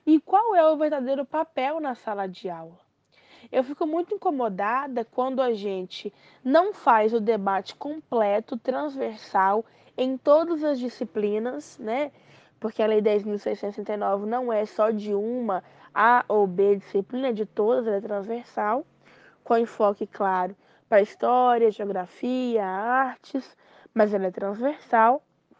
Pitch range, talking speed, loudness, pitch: 205-265 Hz, 135 wpm, -25 LUFS, 230 Hz